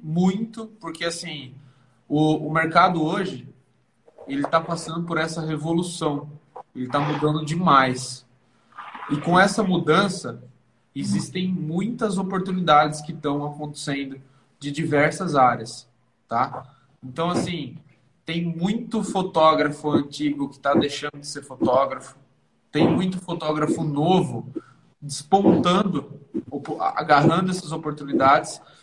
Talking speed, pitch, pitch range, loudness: 105 wpm, 155 Hz, 140-170 Hz, -22 LUFS